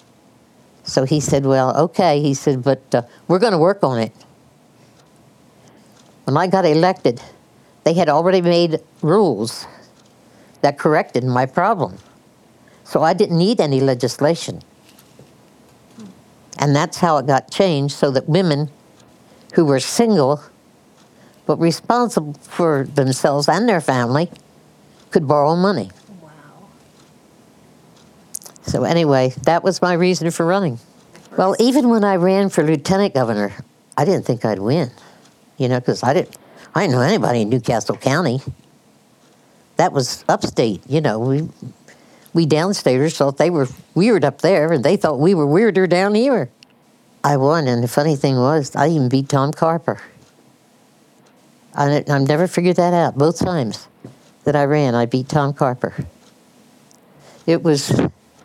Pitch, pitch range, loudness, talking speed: 150 Hz, 135-175 Hz, -17 LUFS, 145 wpm